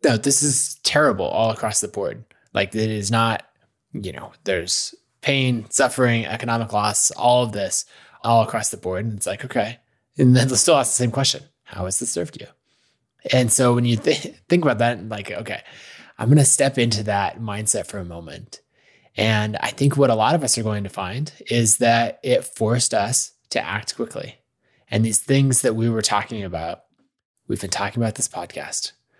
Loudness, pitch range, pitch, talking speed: -20 LUFS, 105-125 Hz, 115 Hz, 200 wpm